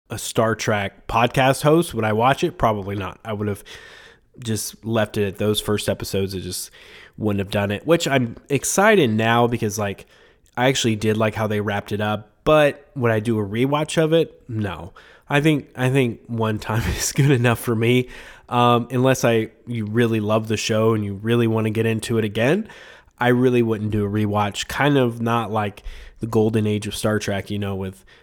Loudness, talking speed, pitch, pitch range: -21 LUFS, 210 wpm, 110 Hz, 105-125 Hz